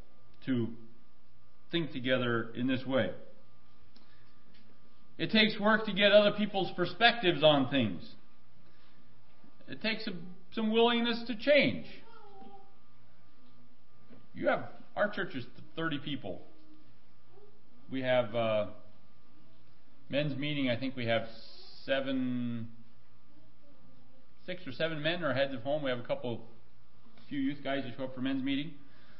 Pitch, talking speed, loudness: 130 Hz, 125 wpm, -31 LUFS